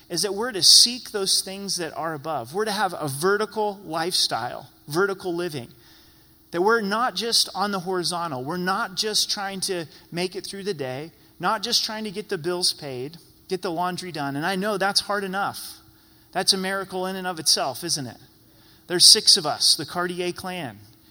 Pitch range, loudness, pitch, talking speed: 165-200 Hz, -22 LUFS, 185 Hz, 195 wpm